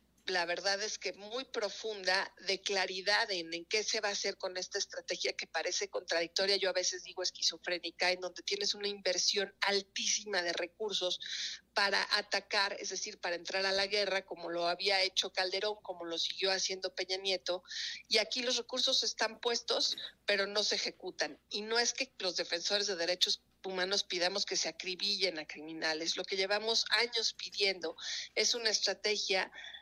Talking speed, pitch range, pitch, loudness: 175 wpm, 180-210 Hz, 195 Hz, -33 LUFS